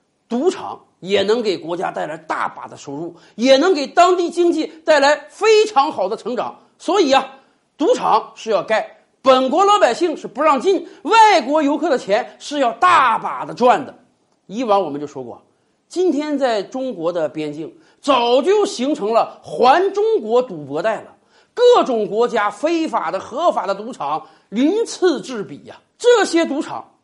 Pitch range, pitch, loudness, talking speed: 225-355 Hz, 290 Hz, -17 LUFS, 240 characters per minute